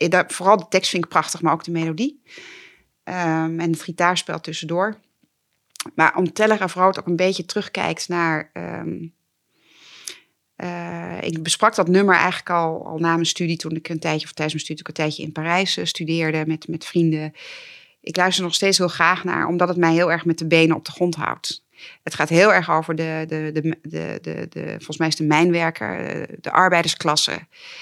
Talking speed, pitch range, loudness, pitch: 205 wpm, 160-180 Hz, -20 LUFS, 170 Hz